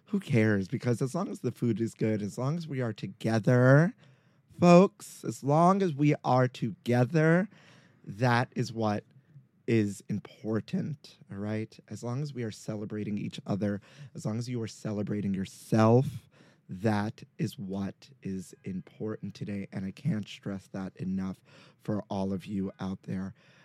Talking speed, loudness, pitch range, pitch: 160 wpm, -30 LUFS, 105-145 Hz, 120 Hz